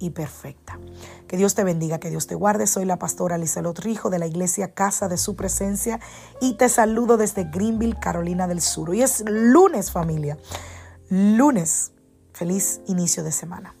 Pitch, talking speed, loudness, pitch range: 185 Hz, 170 wpm, -21 LUFS, 165-210 Hz